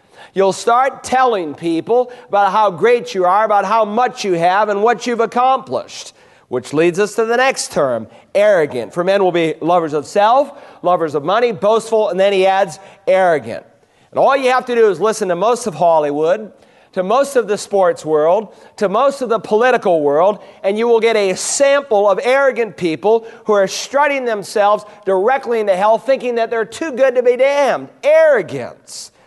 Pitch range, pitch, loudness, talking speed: 190-250 Hz, 215 Hz, -15 LUFS, 185 wpm